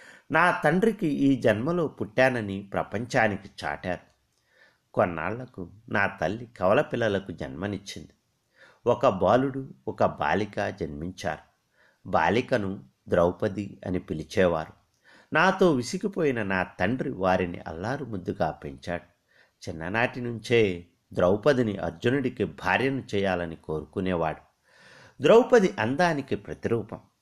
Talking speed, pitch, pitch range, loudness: 85 wpm, 100 Hz, 90-130 Hz, -26 LUFS